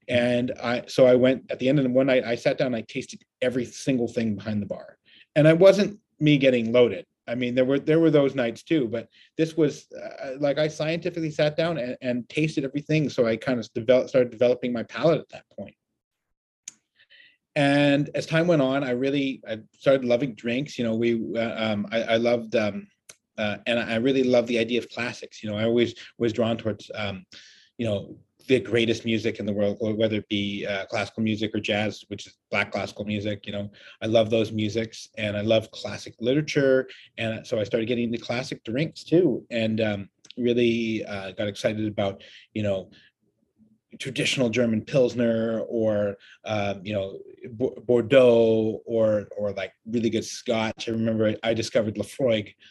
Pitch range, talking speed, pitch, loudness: 110-130 Hz, 190 wpm, 115 Hz, -24 LUFS